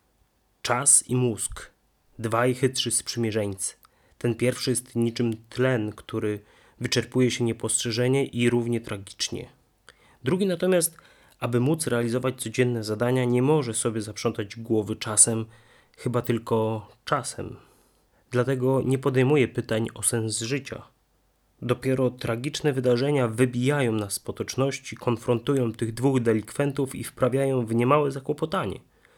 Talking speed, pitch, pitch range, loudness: 120 wpm, 120 Hz, 115-130 Hz, -25 LUFS